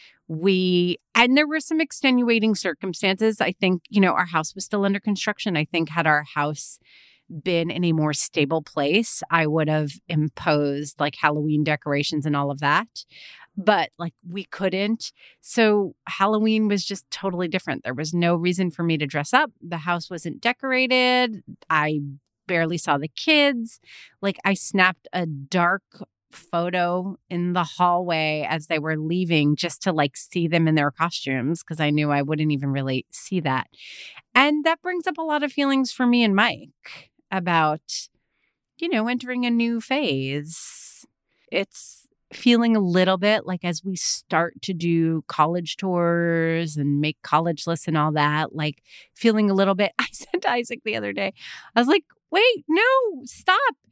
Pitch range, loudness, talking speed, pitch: 155-215 Hz, -22 LUFS, 170 wpm, 175 Hz